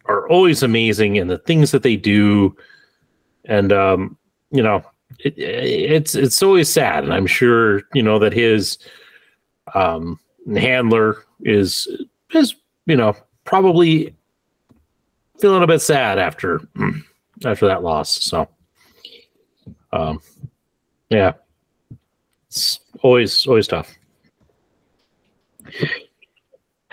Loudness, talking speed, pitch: -16 LUFS, 105 wpm, 125 Hz